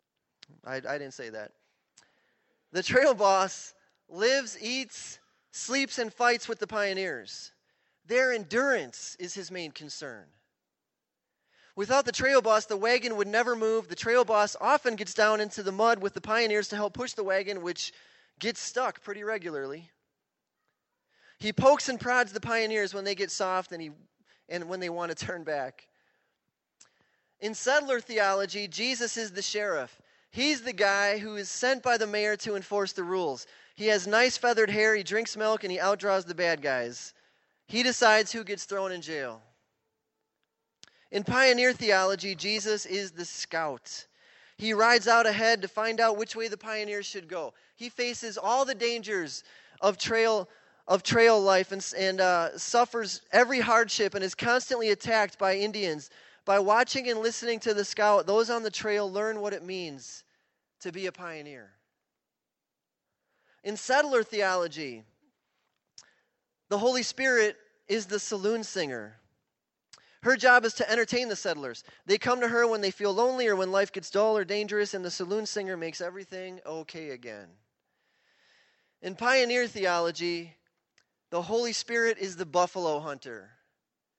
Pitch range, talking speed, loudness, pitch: 190-235 Hz, 160 wpm, -27 LUFS, 210 Hz